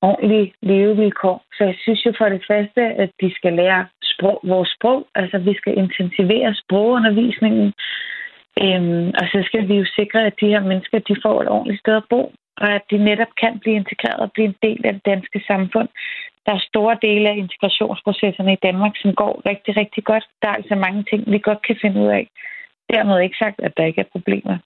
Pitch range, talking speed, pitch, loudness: 195-220 Hz, 210 wpm, 205 Hz, -18 LUFS